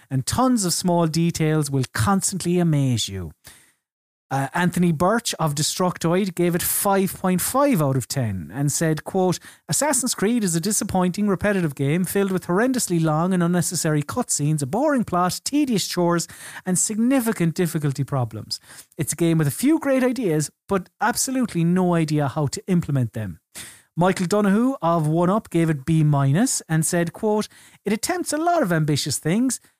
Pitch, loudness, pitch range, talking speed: 175 Hz, -21 LUFS, 155-205 Hz, 160 wpm